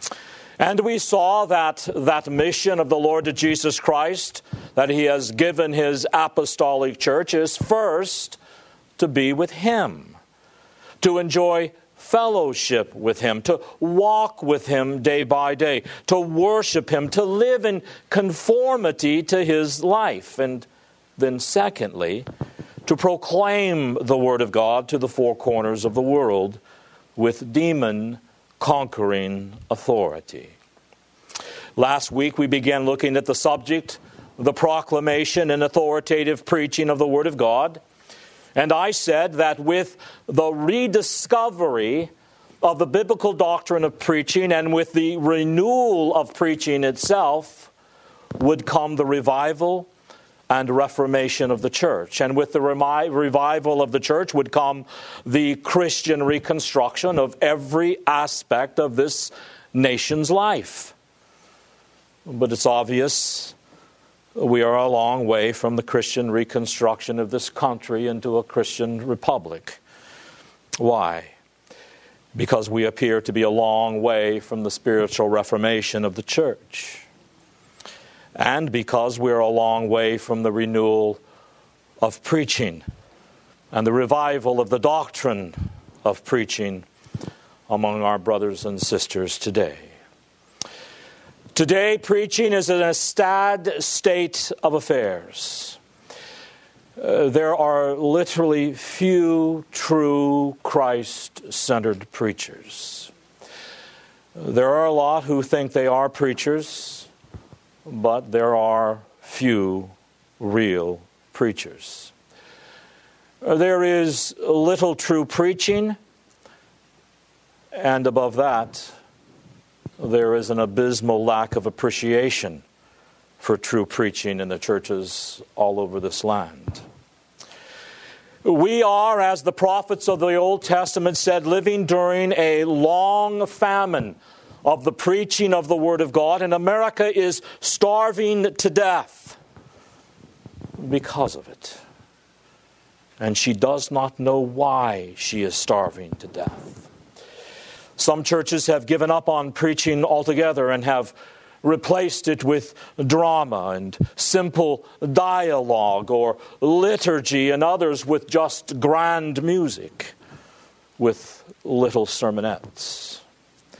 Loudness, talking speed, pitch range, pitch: -21 LUFS, 120 wpm, 125-175 Hz, 150 Hz